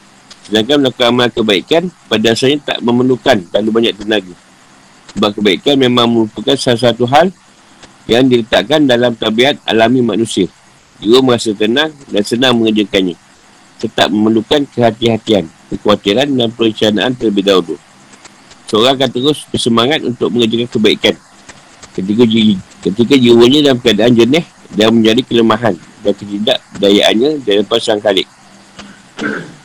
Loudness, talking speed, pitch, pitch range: -11 LUFS, 115 wpm, 115 Hz, 105-125 Hz